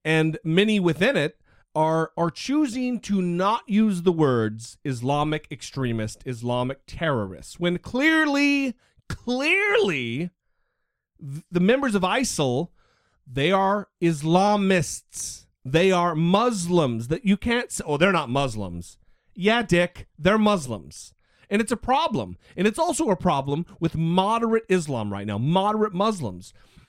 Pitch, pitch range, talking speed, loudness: 175 Hz, 135-210 Hz, 125 wpm, -23 LUFS